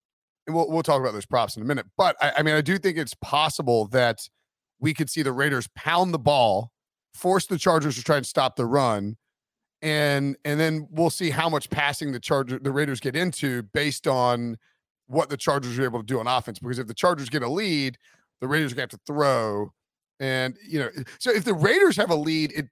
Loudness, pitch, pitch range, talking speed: -24 LUFS, 145 Hz, 130-160 Hz, 225 wpm